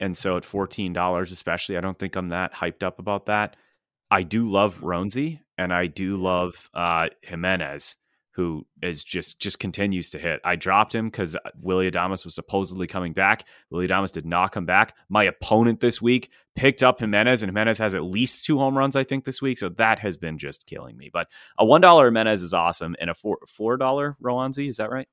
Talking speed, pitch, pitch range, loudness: 210 wpm, 95 Hz, 90-115 Hz, -23 LUFS